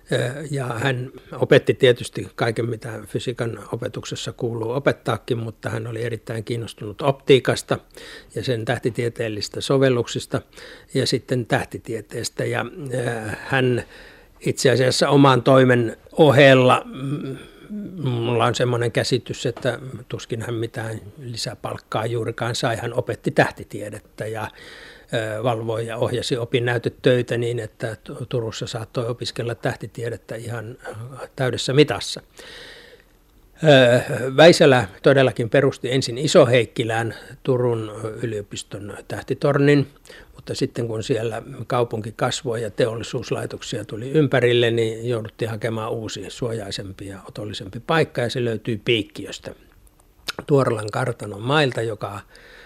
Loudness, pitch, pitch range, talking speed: -21 LUFS, 120 Hz, 115-135 Hz, 105 wpm